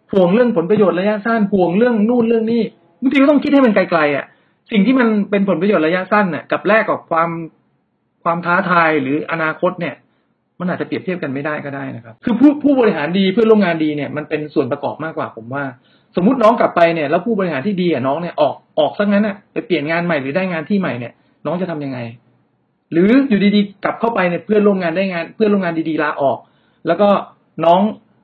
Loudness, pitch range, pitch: -16 LUFS, 155-210 Hz, 180 Hz